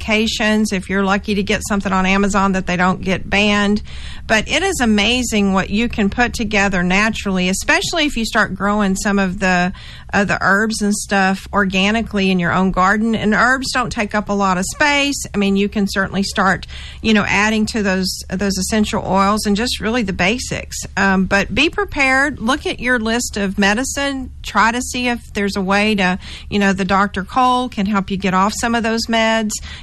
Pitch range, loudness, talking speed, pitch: 195-225 Hz, -16 LUFS, 205 wpm, 205 Hz